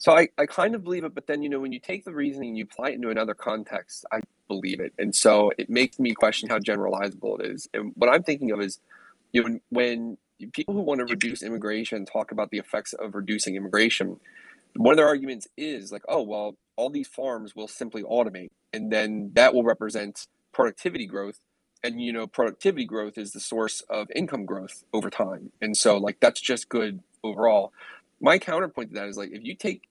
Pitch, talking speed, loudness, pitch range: 115 Hz, 220 wpm, -26 LUFS, 105-140 Hz